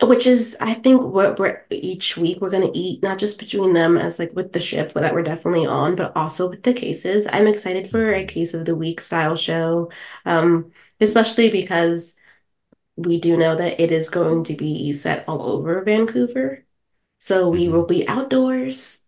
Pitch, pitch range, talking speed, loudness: 185 Hz, 170-220 Hz, 190 wpm, -19 LUFS